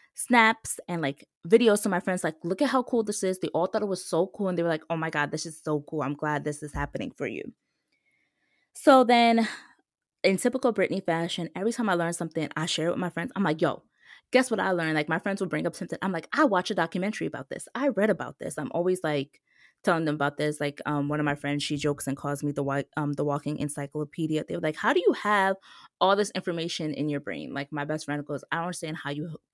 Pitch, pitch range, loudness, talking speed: 165 Hz, 150-195 Hz, -27 LUFS, 265 wpm